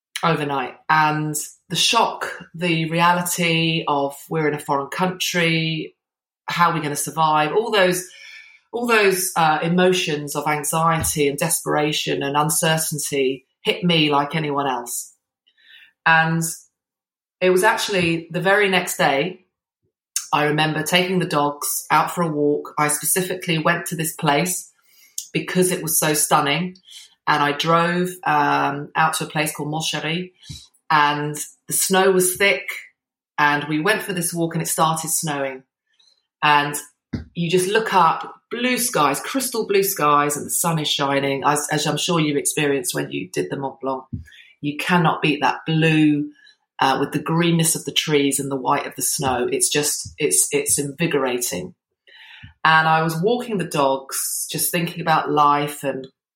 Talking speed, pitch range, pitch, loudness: 160 wpm, 145-180 Hz, 160 Hz, -19 LUFS